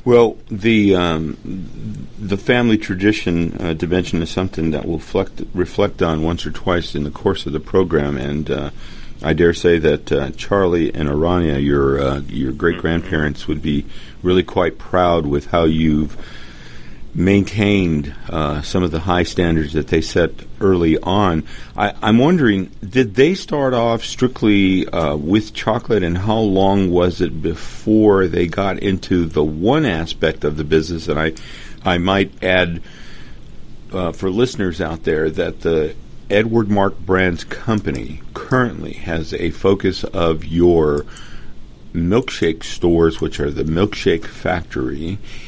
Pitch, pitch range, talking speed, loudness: 85 Hz, 80-100 Hz, 150 wpm, -18 LUFS